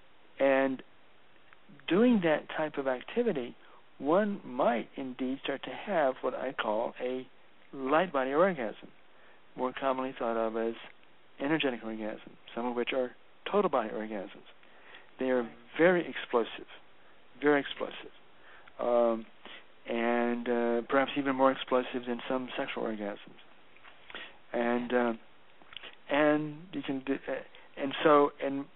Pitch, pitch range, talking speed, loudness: 130 Hz, 120-140 Hz, 125 wpm, -31 LUFS